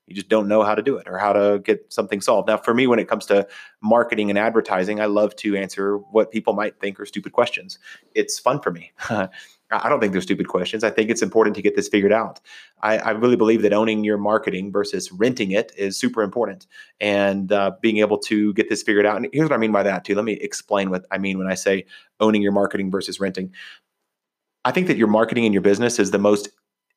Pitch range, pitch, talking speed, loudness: 100-110 Hz, 105 Hz, 245 wpm, -20 LUFS